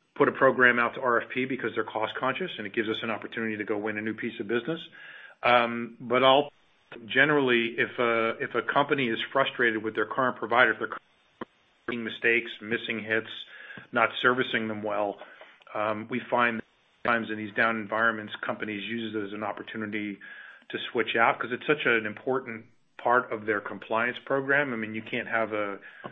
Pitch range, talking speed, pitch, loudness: 110-125 Hz, 190 wpm, 115 Hz, -27 LUFS